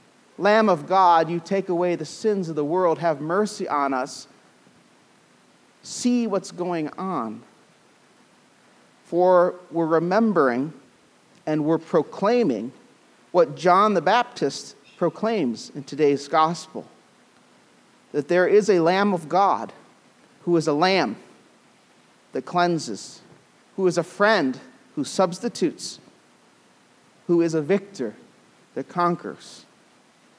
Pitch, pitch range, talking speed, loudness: 175 Hz, 160-195 Hz, 115 wpm, -22 LUFS